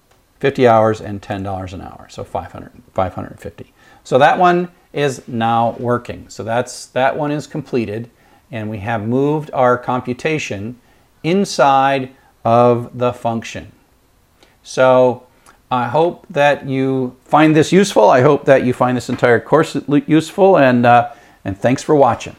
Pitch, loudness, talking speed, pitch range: 125 Hz, -15 LUFS, 145 wpm, 115-145 Hz